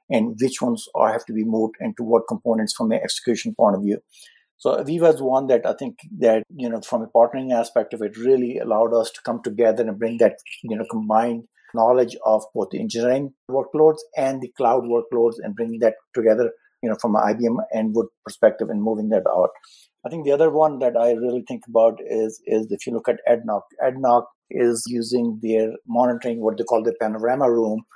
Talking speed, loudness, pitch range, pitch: 210 wpm, -21 LUFS, 110-130 Hz, 115 Hz